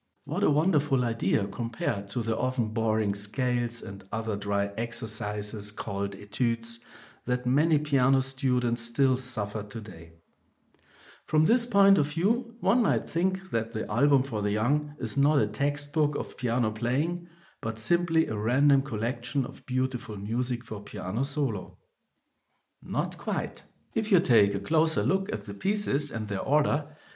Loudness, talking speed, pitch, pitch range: -28 LUFS, 150 wpm, 125 Hz, 110-145 Hz